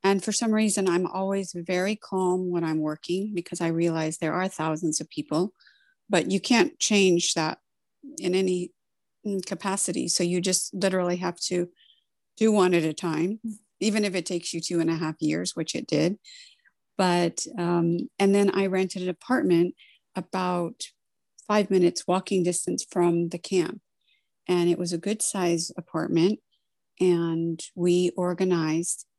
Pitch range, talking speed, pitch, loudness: 170-195 Hz, 160 wpm, 180 Hz, -26 LUFS